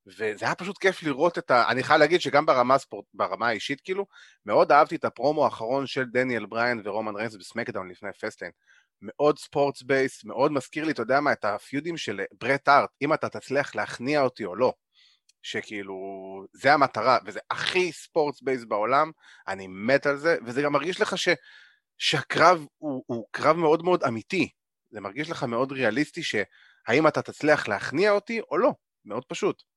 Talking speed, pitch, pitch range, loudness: 175 wpm, 140 Hz, 120-155 Hz, -25 LUFS